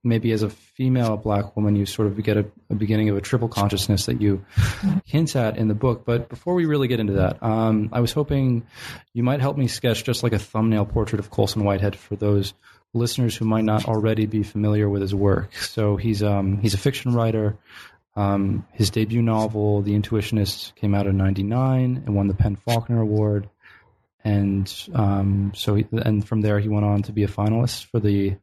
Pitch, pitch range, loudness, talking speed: 110 Hz, 100-115 Hz, -22 LUFS, 210 wpm